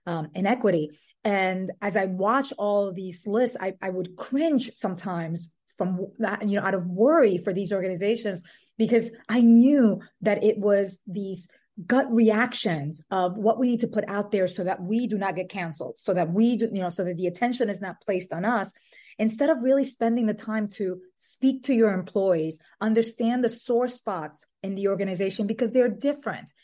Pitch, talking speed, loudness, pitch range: 205 Hz, 190 wpm, -25 LUFS, 185-230 Hz